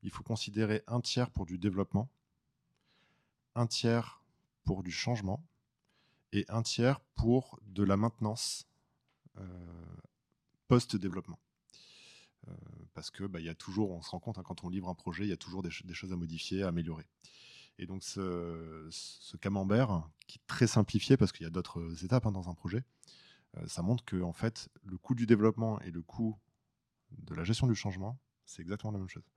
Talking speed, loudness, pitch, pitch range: 190 wpm, -35 LUFS, 105 Hz, 90-120 Hz